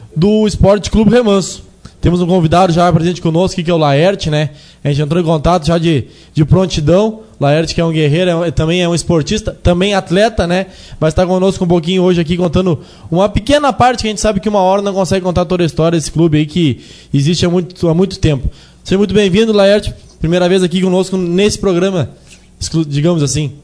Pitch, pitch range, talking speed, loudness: 180 Hz, 165-190 Hz, 210 wpm, -12 LUFS